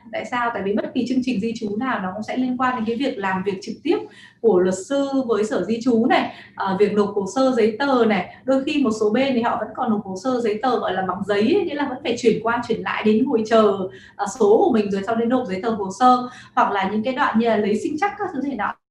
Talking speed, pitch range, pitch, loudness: 290 wpm, 210-260 Hz, 230 Hz, -21 LUFS